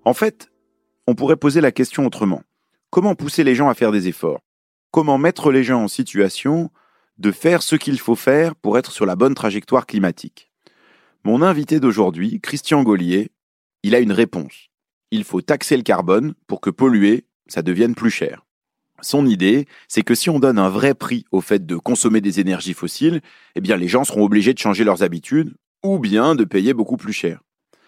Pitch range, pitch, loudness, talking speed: 100-150 Hz, 125 Hz, -18 LUFS, 195 wpm